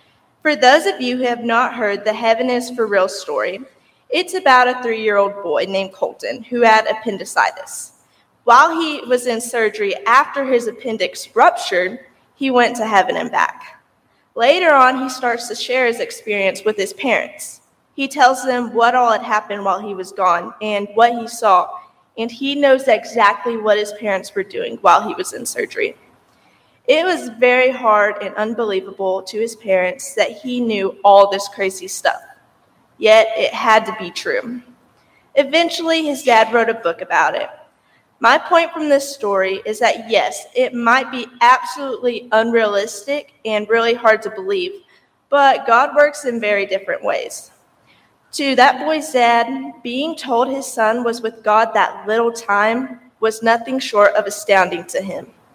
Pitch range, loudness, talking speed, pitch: 215-275 Hz, -16 LUFS, 170 wpm, 235 Hz